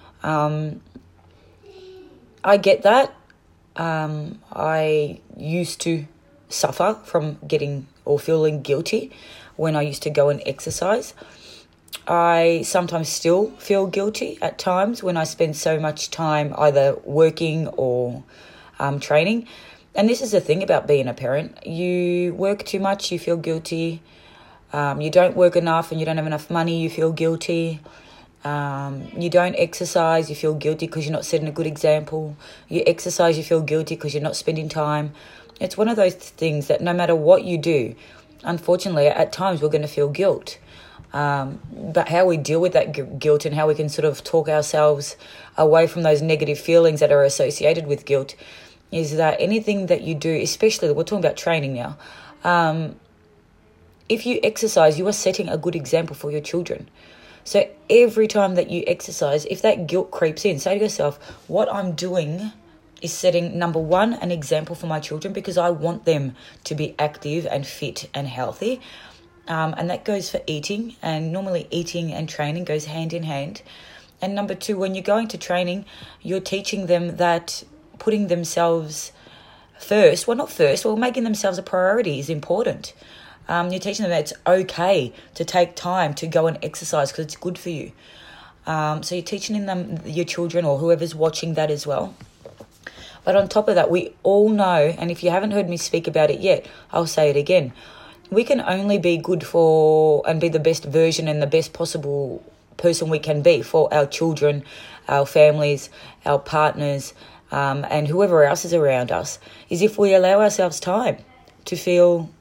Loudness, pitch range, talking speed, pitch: -21 LUFS, 150-180 Hz, 180 wpm, 165 Hz